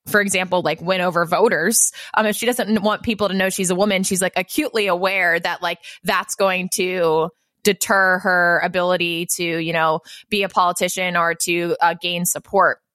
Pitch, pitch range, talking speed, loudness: 185 Hz, 170-195 Hz, 185 wpm, -19 LUFS